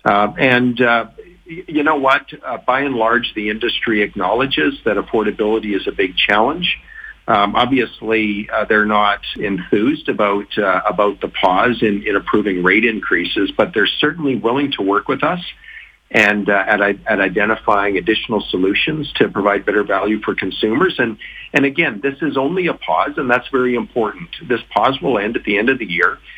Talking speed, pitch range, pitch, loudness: 175 wpm, 105-125 Hz, 110 Hz, -16 LUFS